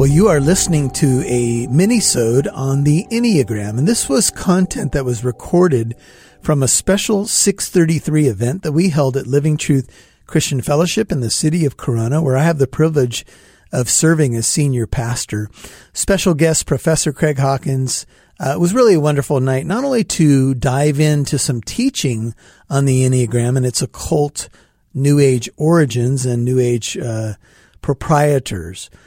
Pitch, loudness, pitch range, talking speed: 140 Hz, -16 LUFS, 125-160 Hz, 160 wpm